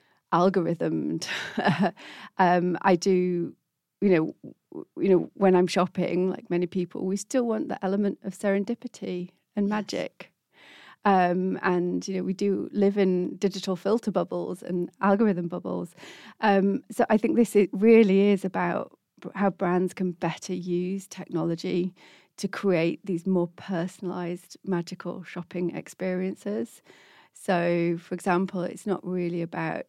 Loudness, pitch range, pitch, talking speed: -26 LUFS, 175-200 Hz, 185 Hz, 135 wpm